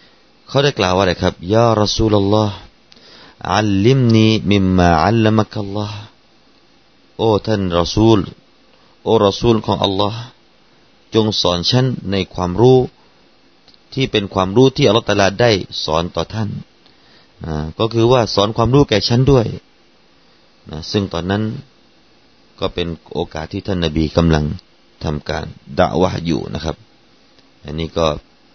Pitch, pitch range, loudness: 100 Hz, 90-115 Hz, -16 LUFS